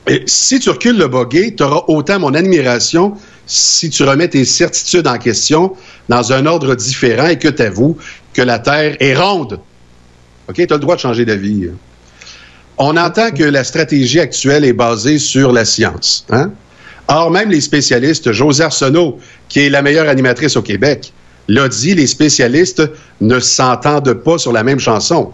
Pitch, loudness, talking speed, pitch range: 135 Hz, -11 LUFS, 175 wpm, 120-160 Hz